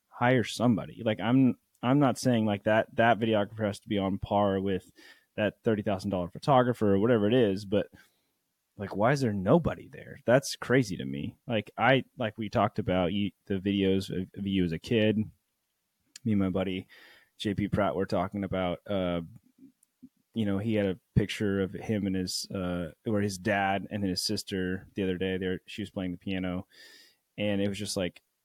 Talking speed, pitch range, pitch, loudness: 190 wpm, 95-110 Hz, 100 Hz, -29 LUFS